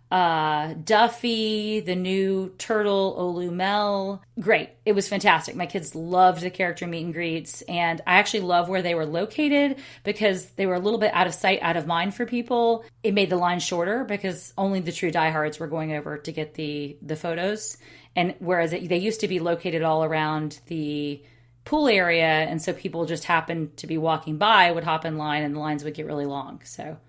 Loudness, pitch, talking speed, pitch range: -24 LUFS, 175 Hz, 205 wpm, 160-200 Hz